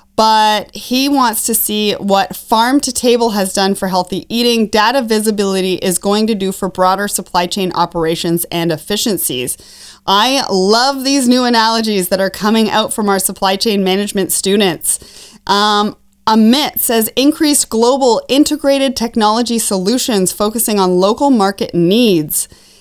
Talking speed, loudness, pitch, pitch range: 145 wpm, -13 LUFS, 210 Hz, 195-235 Hz